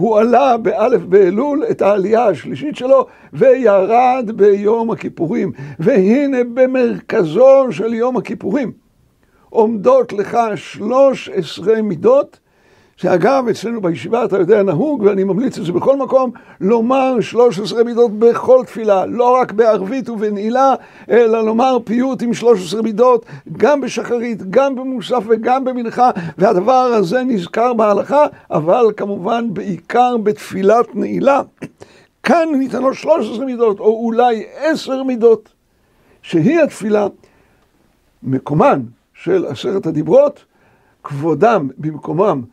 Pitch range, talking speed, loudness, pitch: 200-255 Hz, 110 wpm, -14 LUFS, 230 Hz